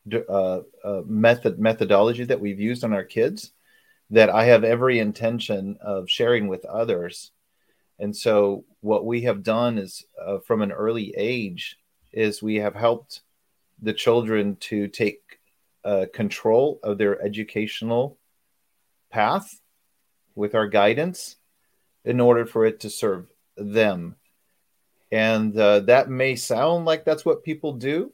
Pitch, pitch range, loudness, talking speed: 110 Hz, 105-120 Hz, -22 LUFS, 140 wpm